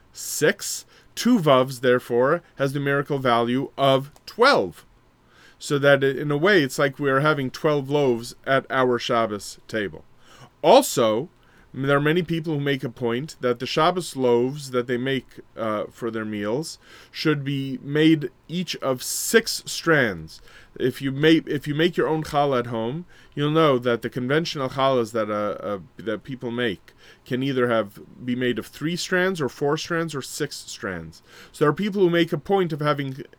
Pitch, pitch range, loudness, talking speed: 135 Hz, 125-150 Hz, -23 LUFS, 180 wpm